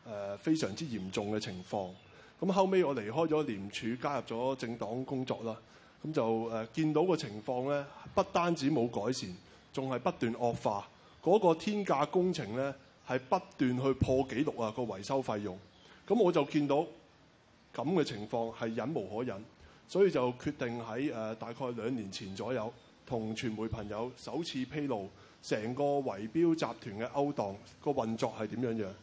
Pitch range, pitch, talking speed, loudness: 110-145 Hz, 125 Hz, 260 characters per minute, -34 LUFS